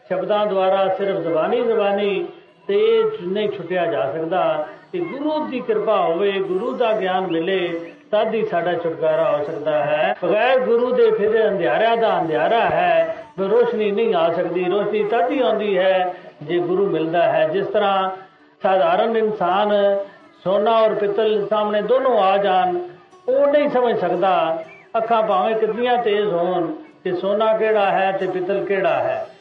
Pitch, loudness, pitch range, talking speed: 210 Hz, -19 LUFS, 185-240 Hz, 150 wpm